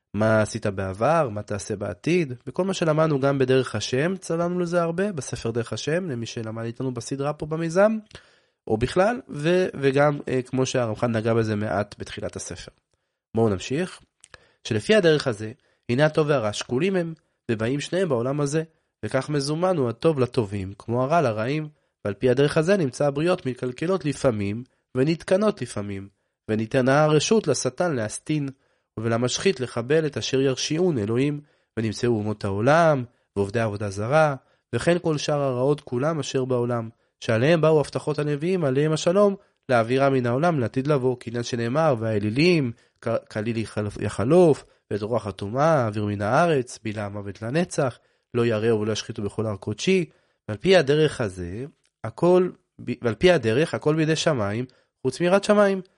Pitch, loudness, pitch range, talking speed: 130 Hz, -23 LUFS, 115-160 Hz, 145 wpm